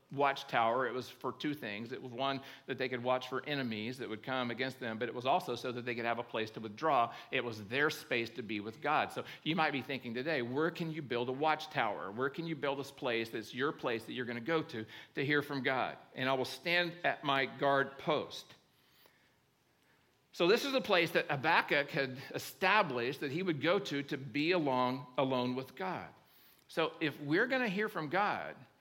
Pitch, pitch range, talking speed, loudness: 135 Hz, 125-150 Hz, 225 wpm, -35 LUFS